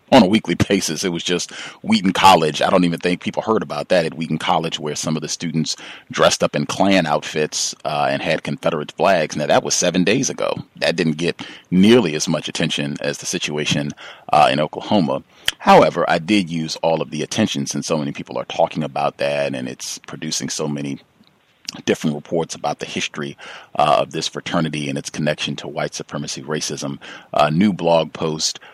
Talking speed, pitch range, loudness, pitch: 200 wpm, 75-85 Hz, -19 LUFS, 80 Hz